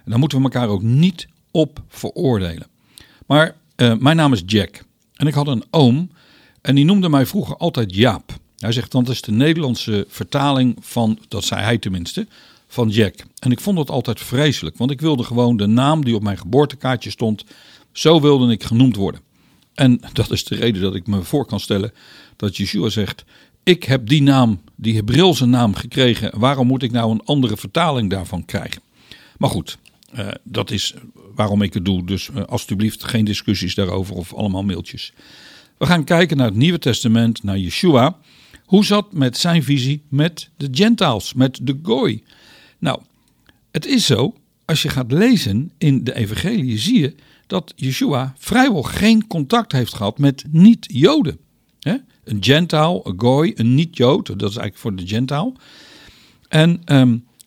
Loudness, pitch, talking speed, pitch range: -17 LUFS, 125 Hz, 180 wpm, 105-150 Hz